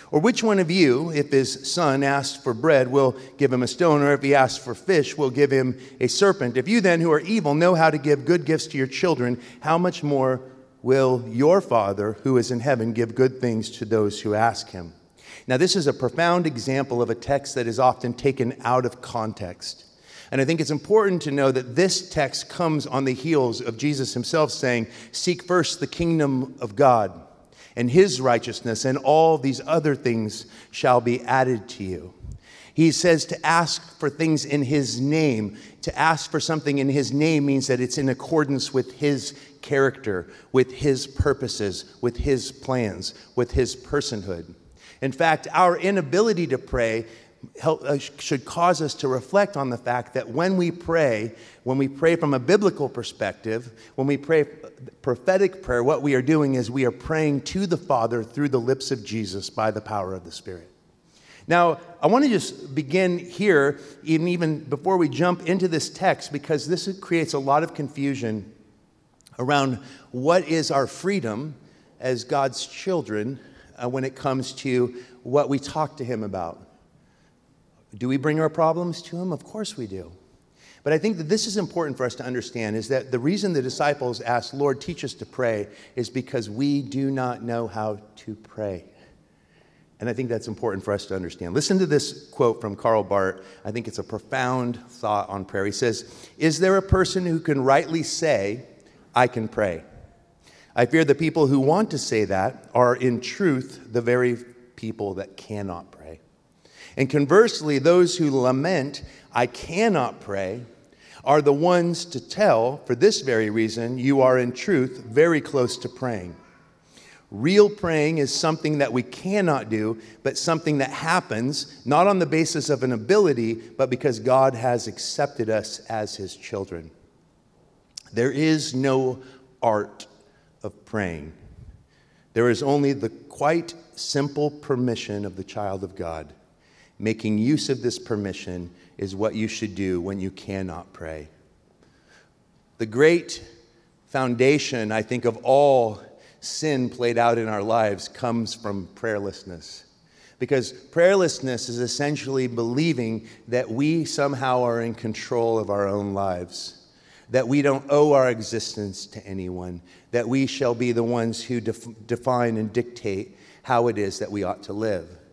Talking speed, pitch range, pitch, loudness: 175 wpm, 115-150 Hz, 130 Hz, -23 LUFS